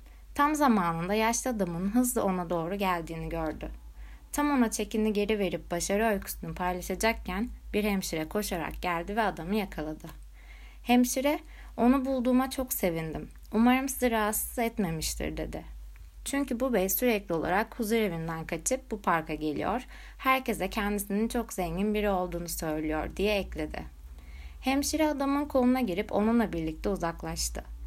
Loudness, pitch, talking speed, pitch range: -29 LUFS, 200 Hz, 130 wpm, 165-235 Hz